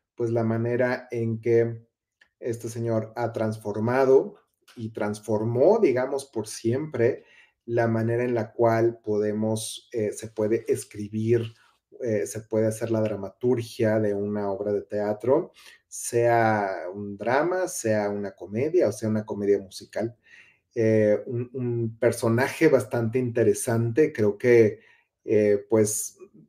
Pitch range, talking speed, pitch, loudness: 105-120 Hz, 125 wpm, 115 Hz, -25 LUFS